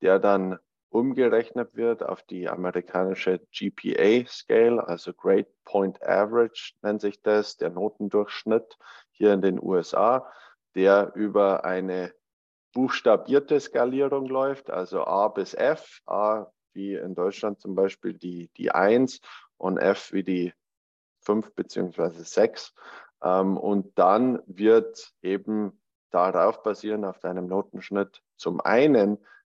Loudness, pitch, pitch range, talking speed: -25 LUFS, 105 Hz, 95-115 Hz, 120 wpm